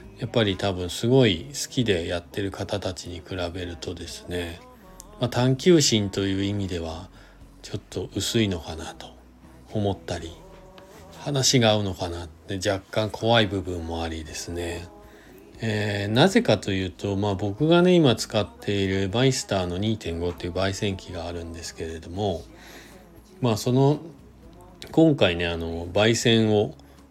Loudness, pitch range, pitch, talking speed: -24 LUFS, 85-110 Hz, 100 Hz, 285 characters per minute